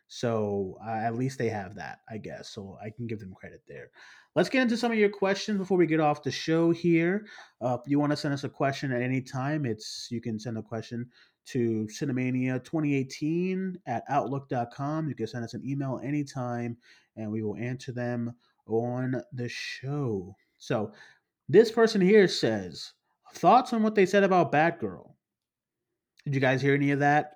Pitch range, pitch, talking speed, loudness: 115-155 Hz, 130 Hz, 190 wpm, -28 LUFS